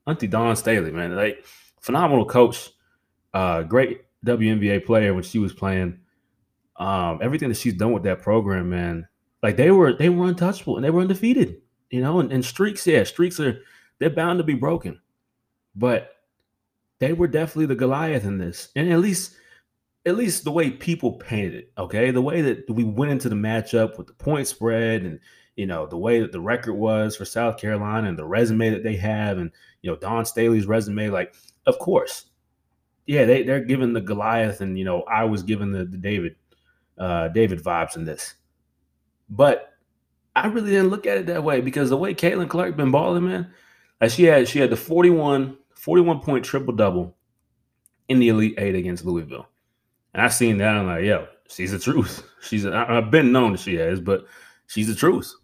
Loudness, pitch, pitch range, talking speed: -21 LUFS, 115 Hz, 100-145 Hz, 195 wpm